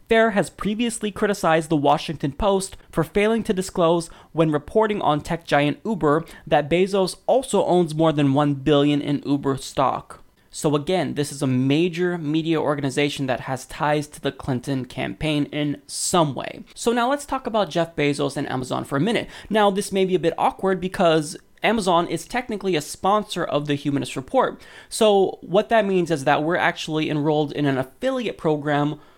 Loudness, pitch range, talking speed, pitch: -22 LUFS, 145-195 Hz, 180 wpm, 165 Hz